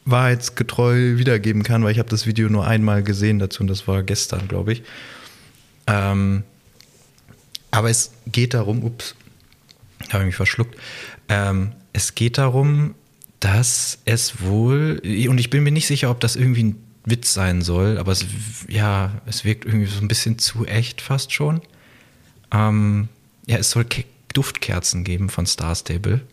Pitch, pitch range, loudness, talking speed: 110 Hz, 100-120 Hz, -20 LUFS, 160 wpm